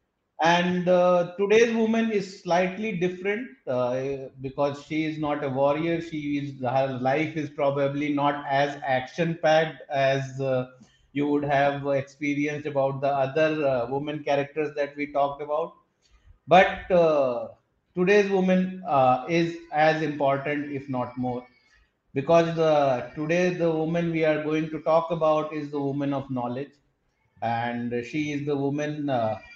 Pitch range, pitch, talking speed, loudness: 135-165 Hz, 145 Hz, 150 wpm, -25 LUFS